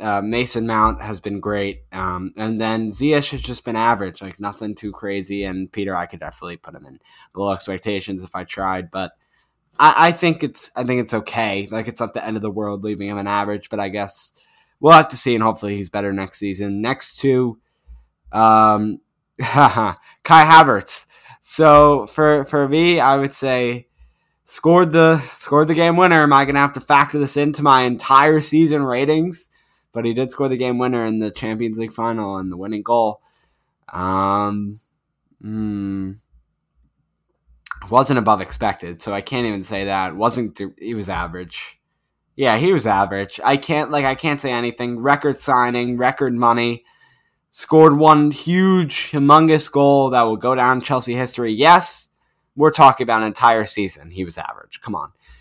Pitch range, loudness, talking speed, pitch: 100-140 Hz, -17 LUFS, 180 wpm, 115 Hz